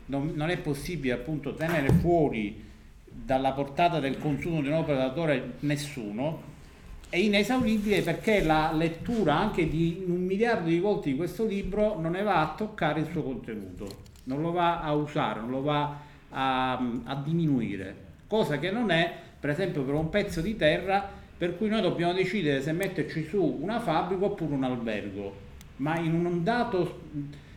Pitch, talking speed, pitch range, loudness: 160 Hz, 165 wpm, 135-180 Hz, -28 LUFS